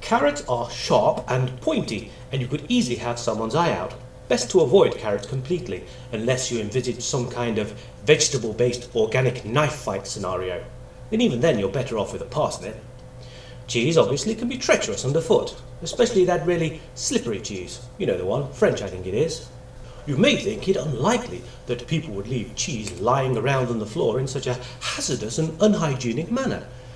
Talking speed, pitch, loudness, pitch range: 180 wpm, 125 Hz, -23 LUFS, 120-150 Hz